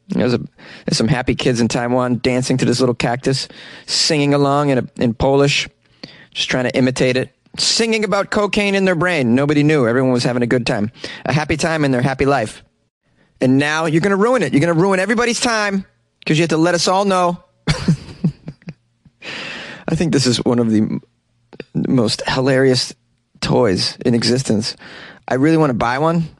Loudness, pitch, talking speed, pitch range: -16 LUFS, 140 Hz, 190 wpm, 125-170 Hz